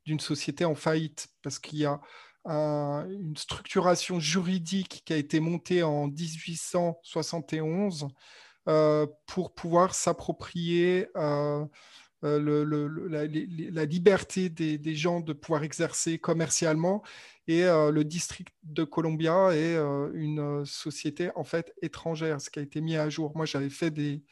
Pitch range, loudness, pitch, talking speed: 150-170 Hz, -29 LUFS, 160 Hz, 150 wpm